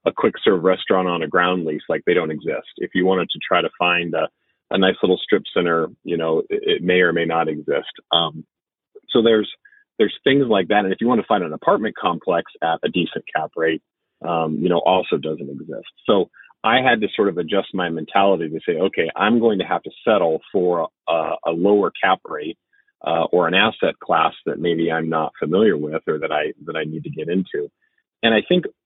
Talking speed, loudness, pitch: 225 wpm, -20 LUFS, 95 Hz